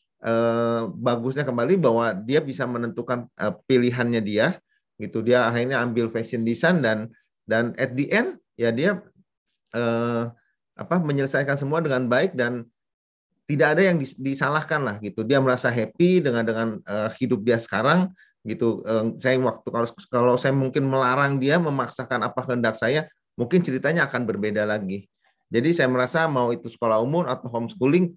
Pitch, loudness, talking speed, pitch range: 125 Hz, -23 LUFS, 160 wpm, 115-140 Hz